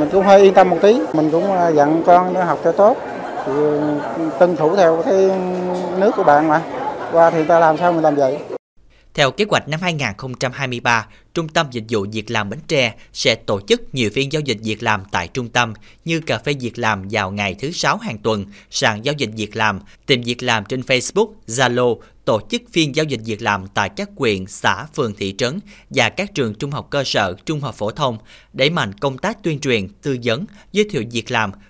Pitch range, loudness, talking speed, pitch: 110-170 Hz, -18 LUFS, 220 wpm, 140 Hz